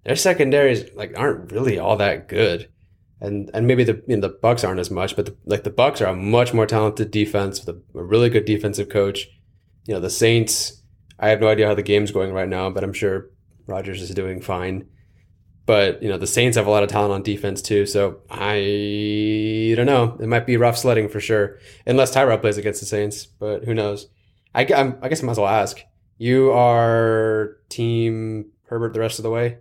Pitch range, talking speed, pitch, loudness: 100-115 Hz, 220 wpm, 105 Hz, -20 LUFS